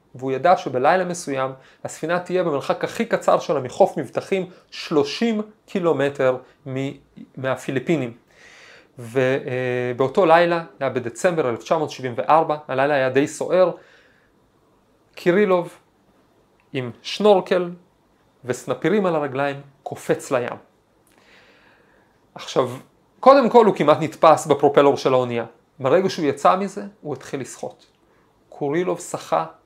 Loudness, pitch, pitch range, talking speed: -20 LUFS, 150 Hz, 130-180 Hz, 105 wpm